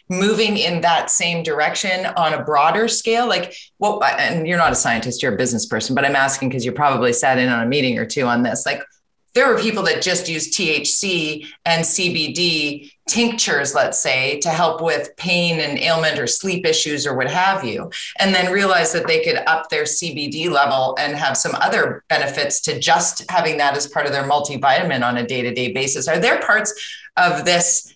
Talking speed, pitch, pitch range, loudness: 205 wpm, 160 Hz, 140-180 Hz, -17 LUFS